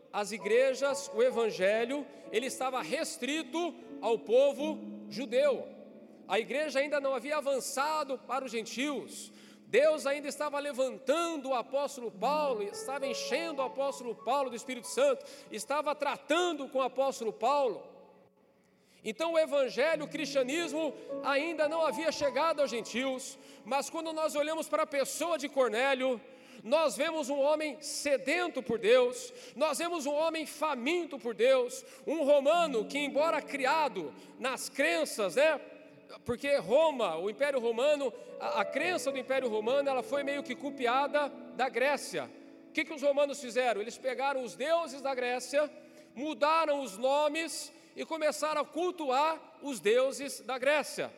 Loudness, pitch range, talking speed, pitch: -32 LUFS, 260-310 Hz, 145 wpm, 280 Hz